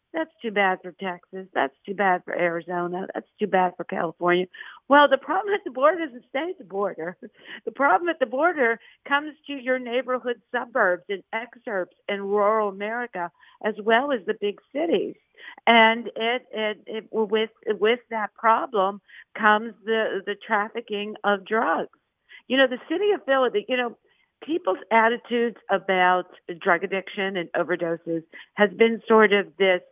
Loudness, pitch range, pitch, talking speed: -24 LUFS, 190-245 Hz, 215 Hz, 160 wpm